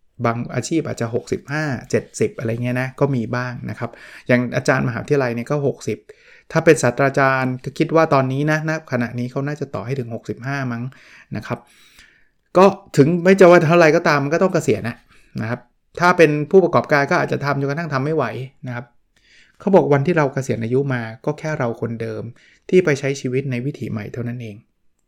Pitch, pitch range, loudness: 135 Hz, 120-155 Hz, -18 LUFS